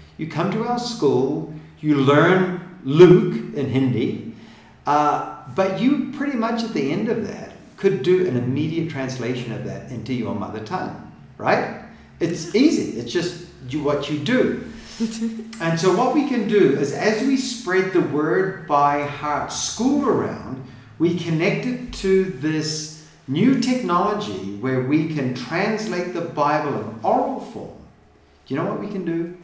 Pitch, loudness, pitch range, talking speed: 170 Hz, -21 LUFS, 145-210 Hz, 160 wpm